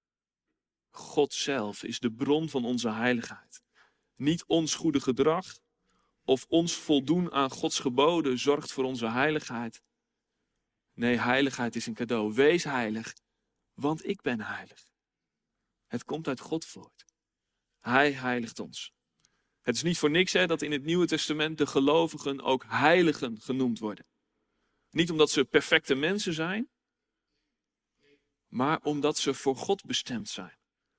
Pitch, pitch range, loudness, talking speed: 145 Hz, 125-160 Hz, -28 LUFS, 140 wpm